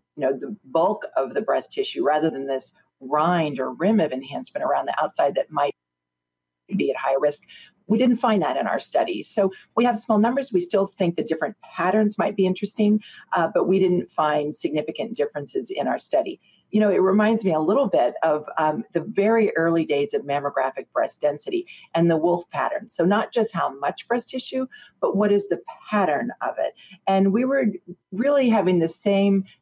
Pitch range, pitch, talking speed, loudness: 155-215 Hz, 190 Hz, 200 wpm, -23 LUFS